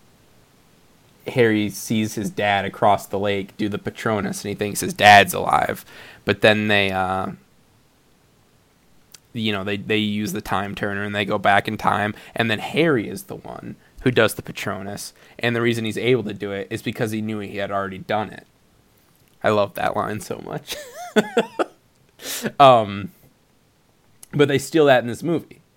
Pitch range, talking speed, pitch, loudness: 100-120 Hz, 175 wpm, 105 Hz, -20 LUFS